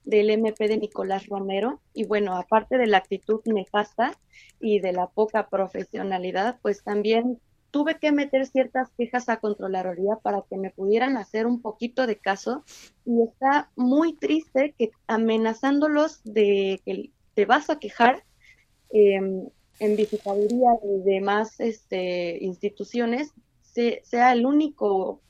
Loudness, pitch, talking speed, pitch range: -24 LUFS, 220 Hz, 135 wpm, 200-250 Hz